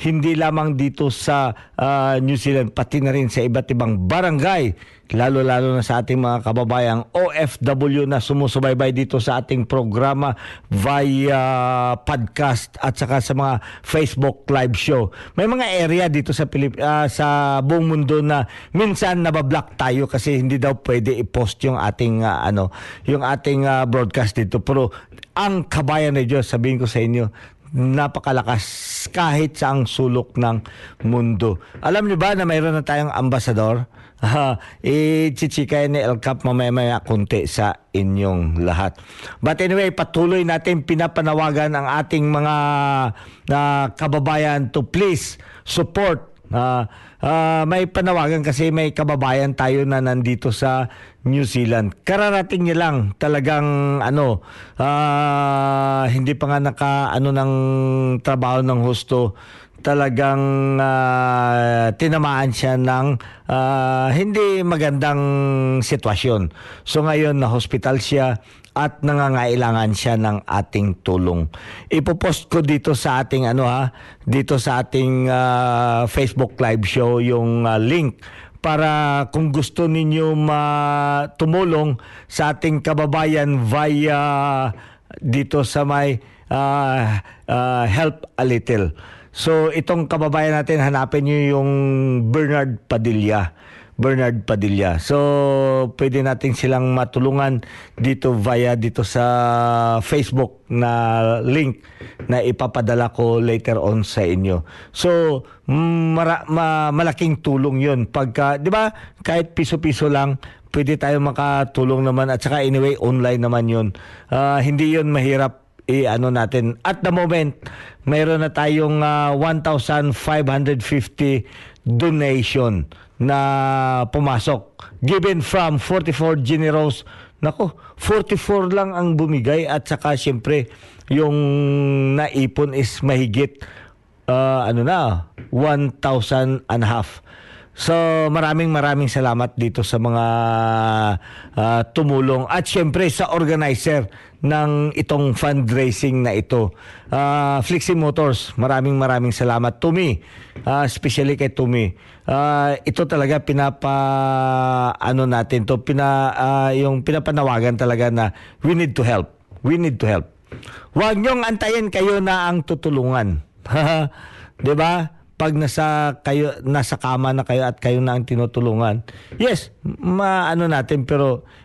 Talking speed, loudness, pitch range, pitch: 125 wpm, -19 LUFS, 120-150 Hz, 135 Hz